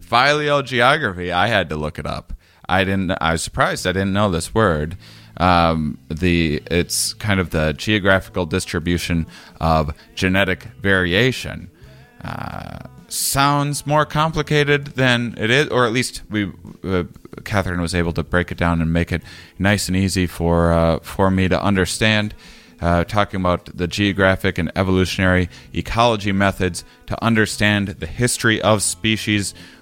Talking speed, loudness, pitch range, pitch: 145 wpm, -19 LUFS, 85-110 Hz, 95 Hz